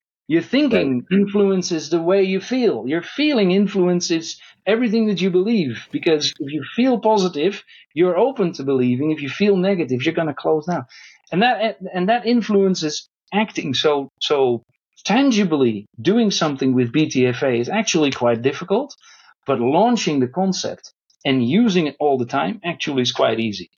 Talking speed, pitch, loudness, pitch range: 160 wpm, 175 Hz, -19 LUFS, 140-205 Hz